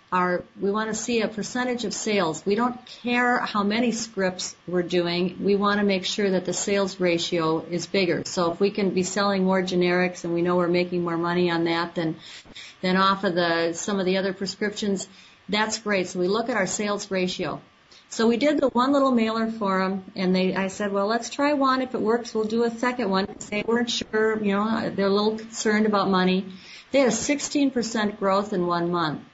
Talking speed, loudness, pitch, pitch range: 220 wpm, -24 LUFS, 200 Hz, 180-225 Hz